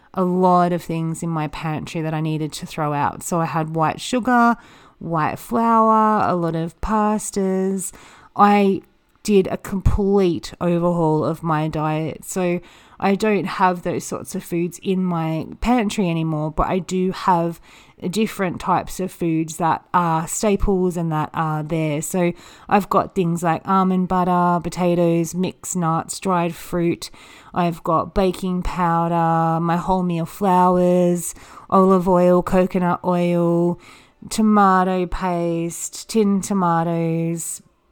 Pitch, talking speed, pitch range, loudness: 175 Hz, 135 wpm, 165-190 Hz, -20 LUFS